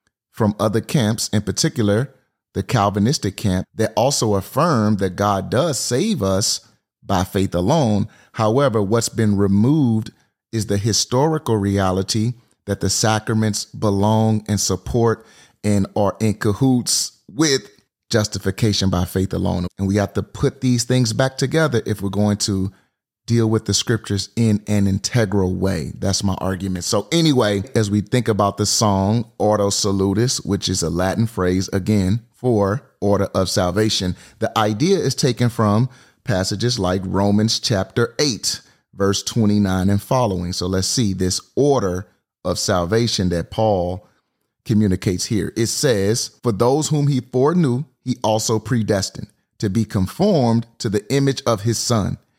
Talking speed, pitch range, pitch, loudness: 150 wpm, 100-115 Hz, 105 Hz, -19 LUFS